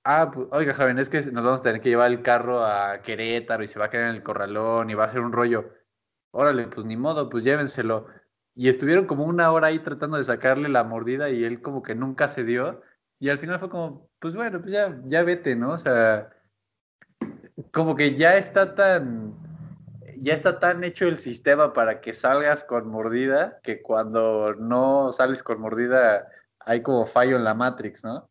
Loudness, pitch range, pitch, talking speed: -23 LUFS, 115-155 Hz, 130 Hz, 205 wpm